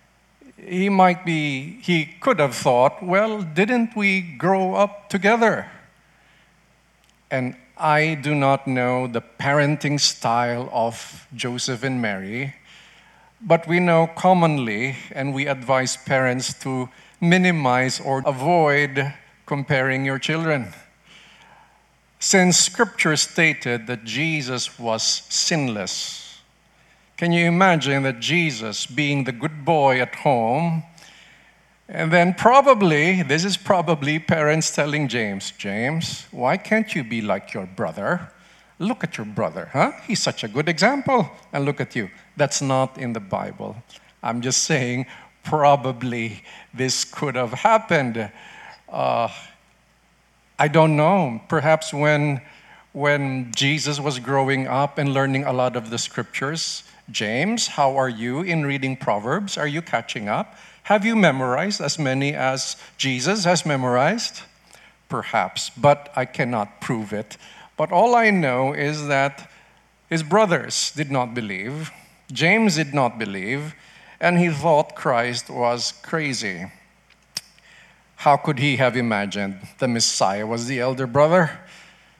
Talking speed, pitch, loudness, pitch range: 130 wpm, 145 Hz, -21 LUFS, 130-170 Hz